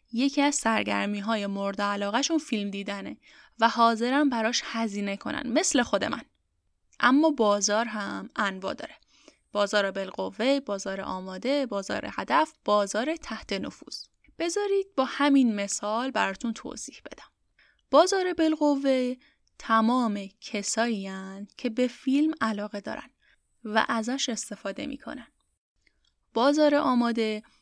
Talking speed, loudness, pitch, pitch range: 115 wpm, -27 LUFS, 230 Hz, 205-280 Hz